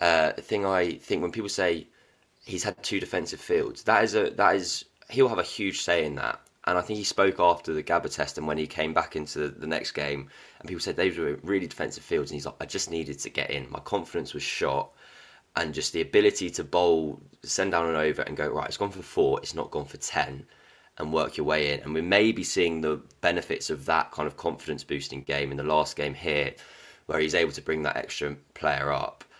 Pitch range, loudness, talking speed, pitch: 75-110 Hz, -28 LUFS, 245 wpm, 85 Hz